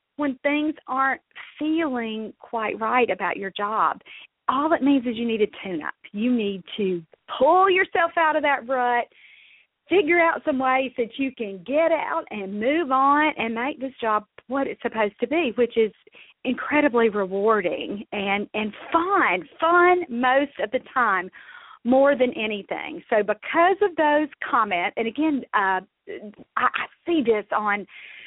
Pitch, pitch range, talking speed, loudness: 260 Hz, 220-315 Hz, 160 wpm, -23 LUFS